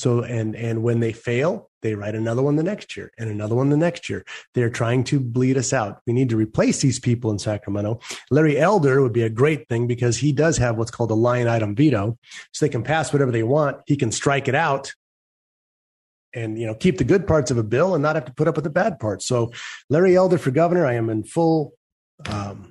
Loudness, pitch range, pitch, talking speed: -21 LUFS, 115-150 Hz, 125 Hz, 245 wpm